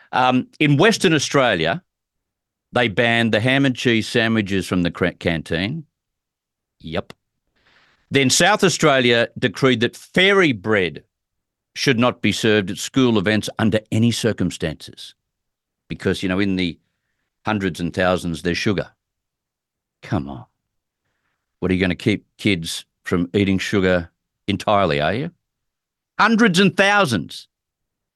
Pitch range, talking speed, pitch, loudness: 95-130 Hz, 130 wpm, 110 Hz, -19 LUFS